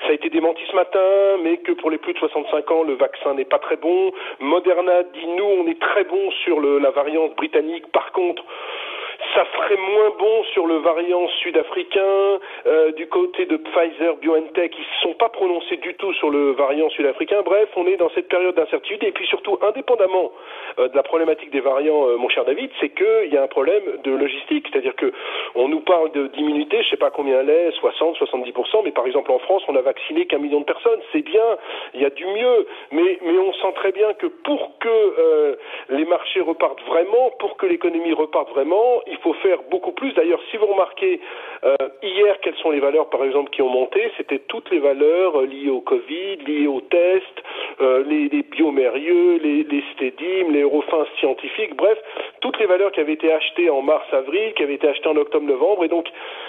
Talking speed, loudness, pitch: 220 wpm, -19 LUFS, 335 Hz